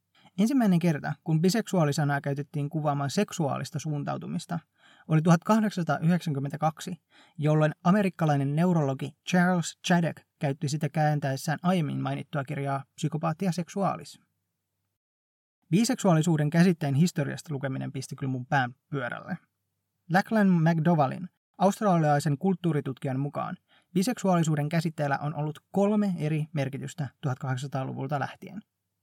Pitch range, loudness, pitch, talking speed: 140-180 Hz, -27 LUFS, 155 Hz, 95 wpm